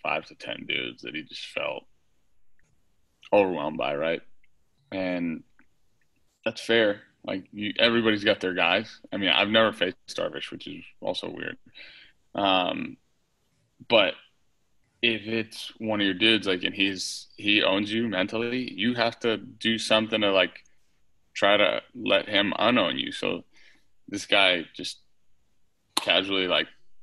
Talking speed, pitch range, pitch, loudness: 140 wpm, 100-115 Hz, 110 Hz, -25 LUFS